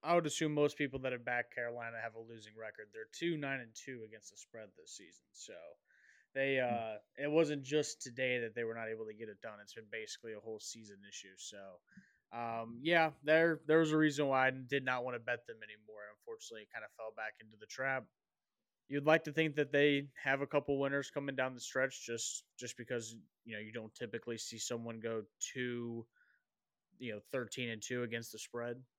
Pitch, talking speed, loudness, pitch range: 120 Hz, 220 wpm, -37 LUFS, 115-140 Hz